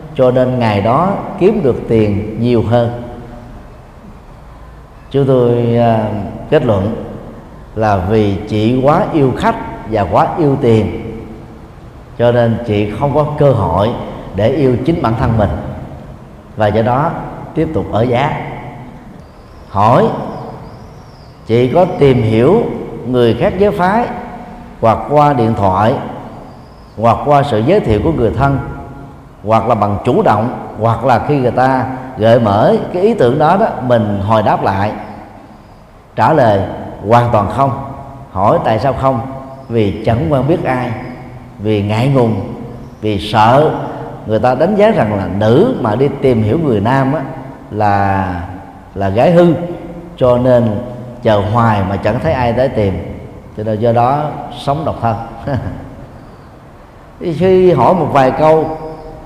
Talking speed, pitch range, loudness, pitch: 145 wpm, 110-140 Hz, -13 LUFS, 120 Hz